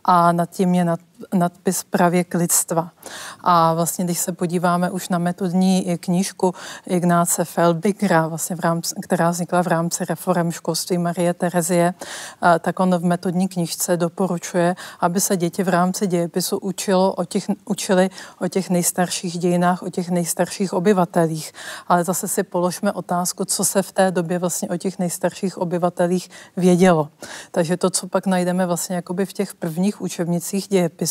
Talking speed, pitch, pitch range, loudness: 150 wpm, 180 Hz, 175-190 Hz, -20 LUFS